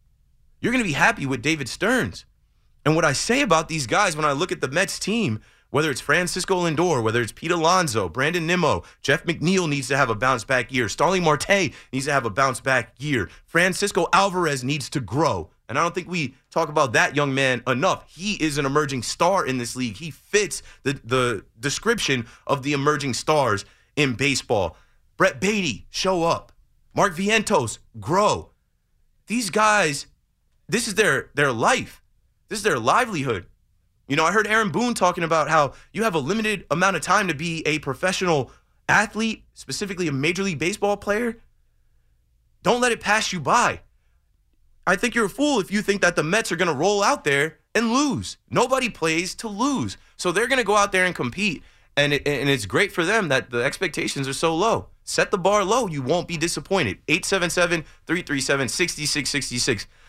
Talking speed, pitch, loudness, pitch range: 190 wpm, 160 Hz, -22 LUFS, 135-195 Hz